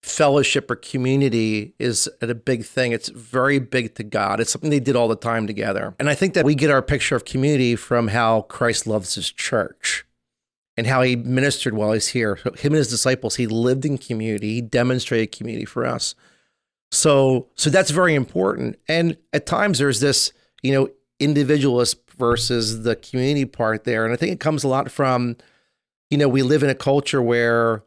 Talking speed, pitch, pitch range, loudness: 195 wpm, 125 Hz, 115-140 Hz, -20 LUFS